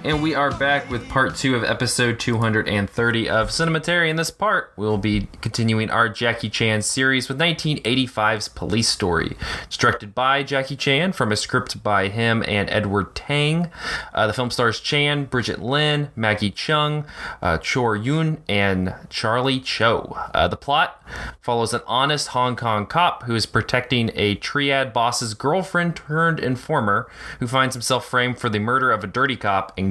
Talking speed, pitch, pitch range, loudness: 170 wpm, 125 Hz, 110-140 Hz, -21 LUFS